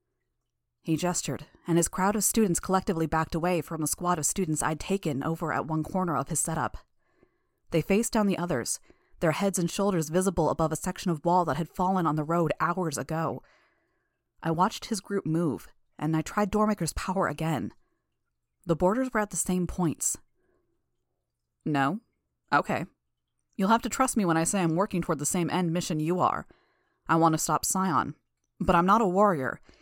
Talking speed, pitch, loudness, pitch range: 190 wpm, 170 Hz, -27 LUFS, 160-190 Hz